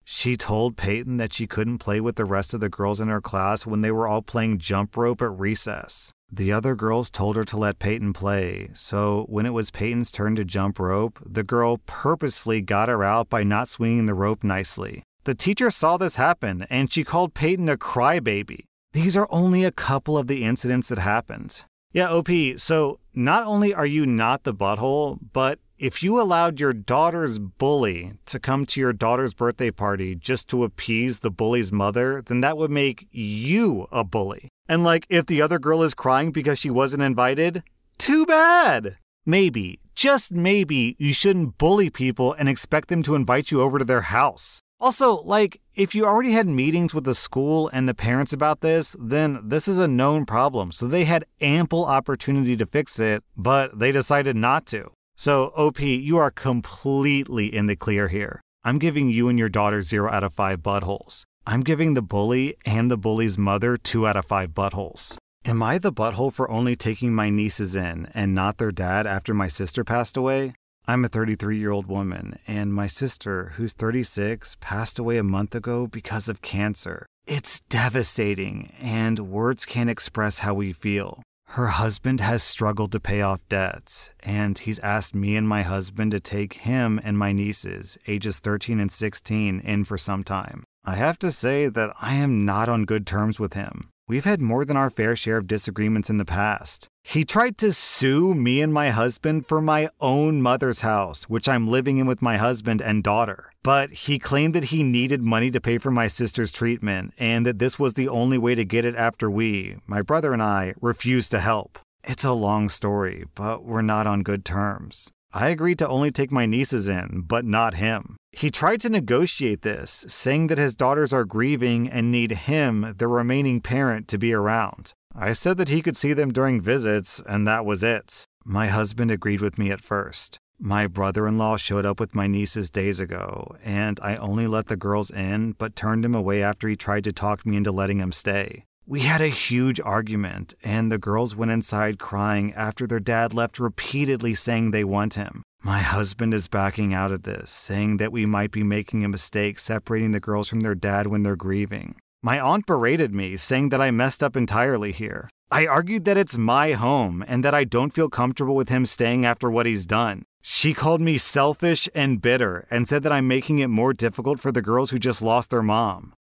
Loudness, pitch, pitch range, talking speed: -23 LUFS, 115 Hz, 105-135 Hz, 200 wpm